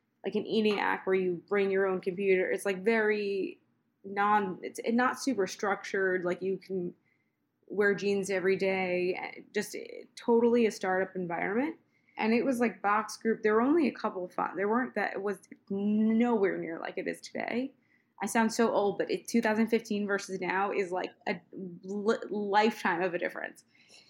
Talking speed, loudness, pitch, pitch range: 180 wpm, -30 LUFS, 205 Hz, 190-225 Hz